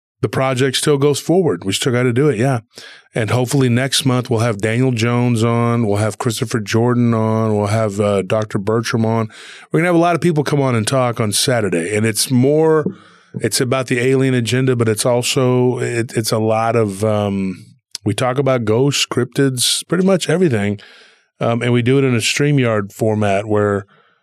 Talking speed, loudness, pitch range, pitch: 205 wpm, -16 LUFS, 110-135 Hz, 120 Hz